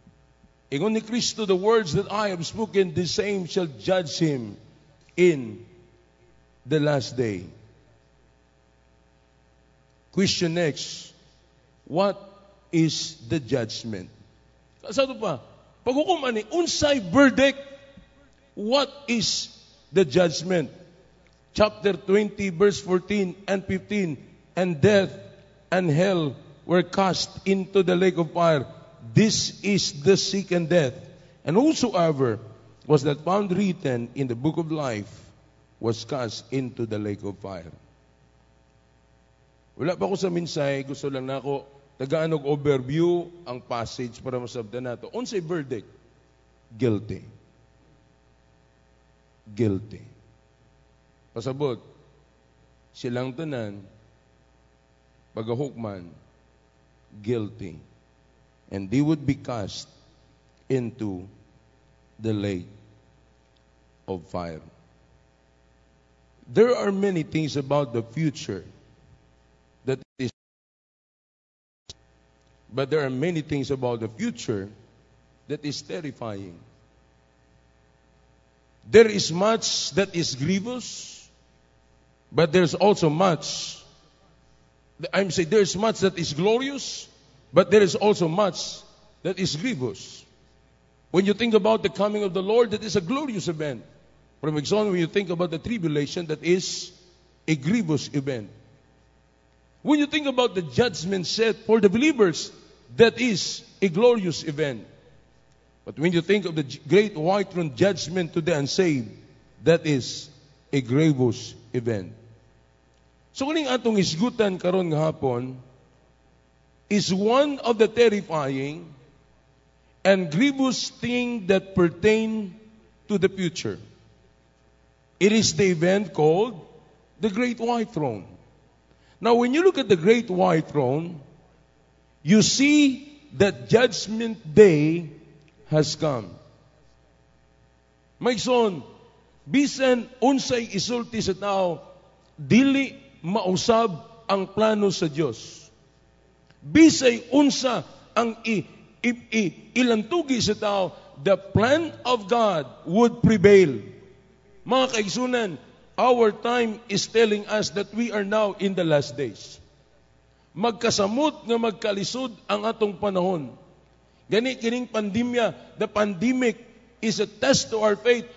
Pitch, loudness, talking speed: 170 Hz, -23 LUFS, 115 wpm